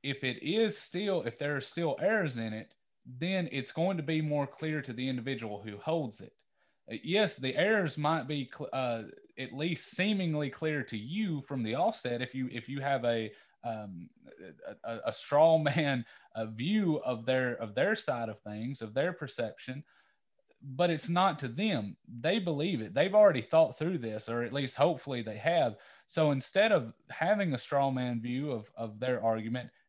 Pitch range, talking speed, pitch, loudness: 120-165 Hz, 190 wpm, 140 Hz, -32 LUFS